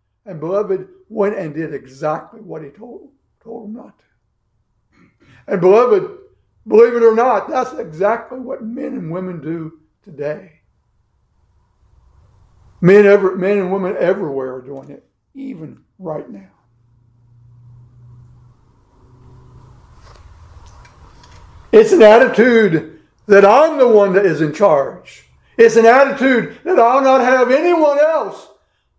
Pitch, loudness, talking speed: 185 Hz, -13 LUFS, 125 wpm